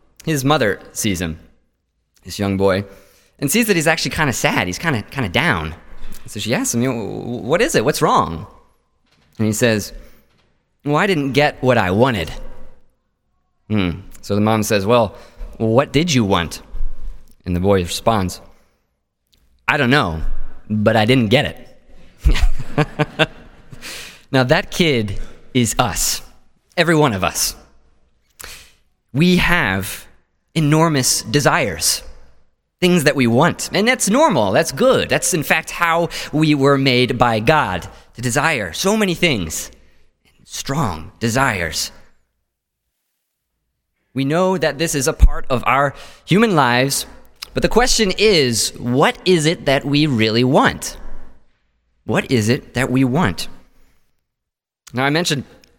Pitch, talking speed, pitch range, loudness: 125 Hz, 140 wpm, 95-155 Hz, -17 LUFS